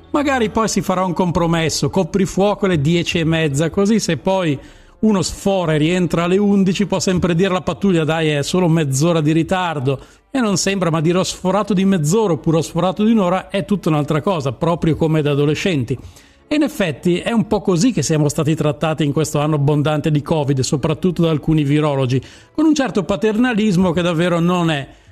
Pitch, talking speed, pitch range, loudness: 170 Hz, 200 wpm, 155-195 Hz, -17 LUFS